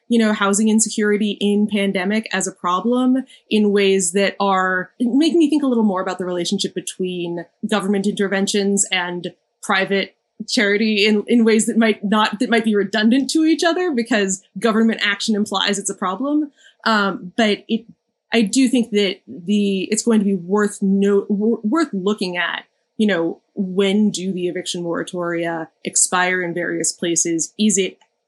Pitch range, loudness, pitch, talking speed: 190-225 Hz, -18 LUFS, 205 Hz, 170 wpm